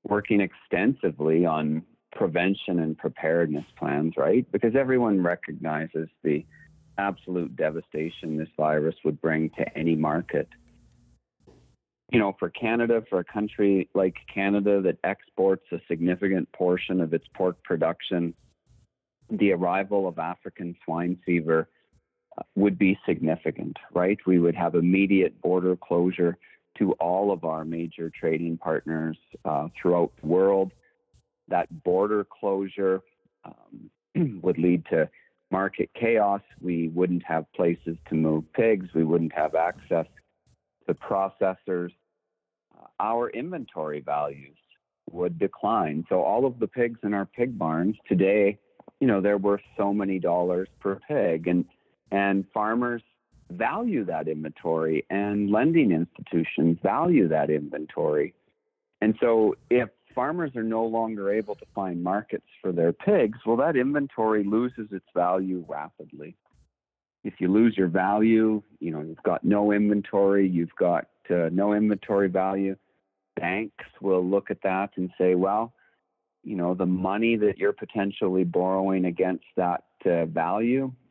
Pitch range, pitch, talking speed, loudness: 85-105 Hz, 95 Hz, 135 wpm, -26 LUFS